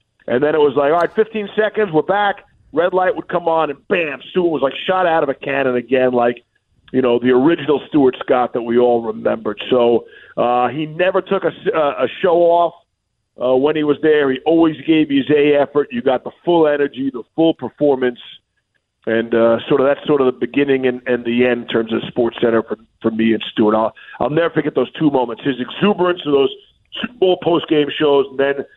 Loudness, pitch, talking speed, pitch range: -16 LUFS, 140 Hz, 225 wpm, 120-165 Hz